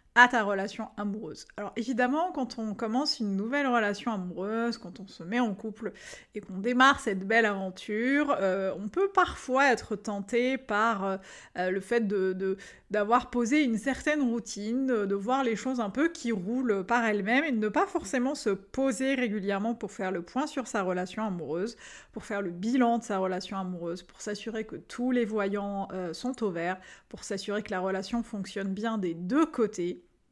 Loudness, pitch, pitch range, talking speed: -29 LUFS, 220 Hz, 195-245 Hz, 190 wpm